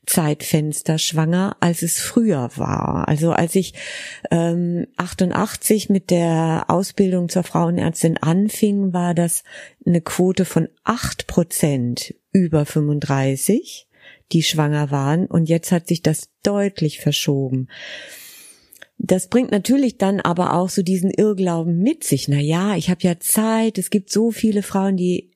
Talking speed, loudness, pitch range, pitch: 135 wpm, -19 LUFS, 160-195 Hz, 175 Hz